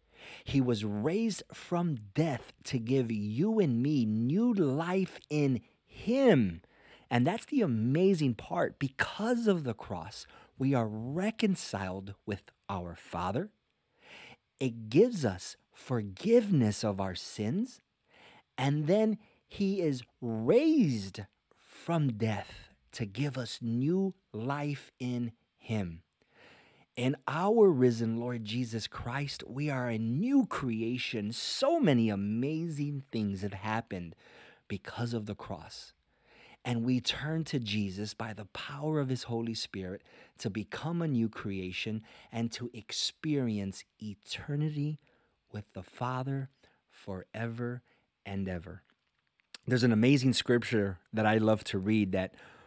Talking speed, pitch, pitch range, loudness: 125 wpm, 120 Hz, 105-145 Hz, -32 LUFS